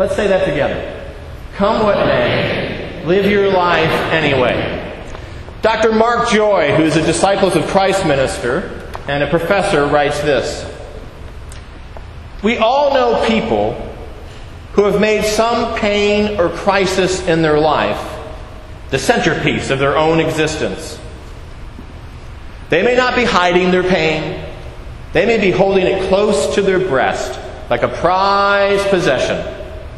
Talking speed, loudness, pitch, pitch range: 130 wpm, -14 LUFS, 190 Hz, 155-205 Hz